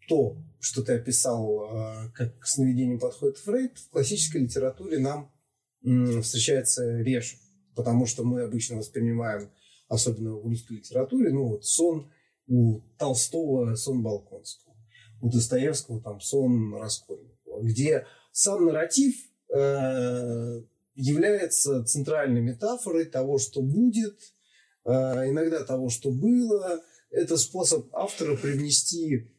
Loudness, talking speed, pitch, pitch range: -26 LUFS, 110 wpm, 130 Hz, 115-155 Hz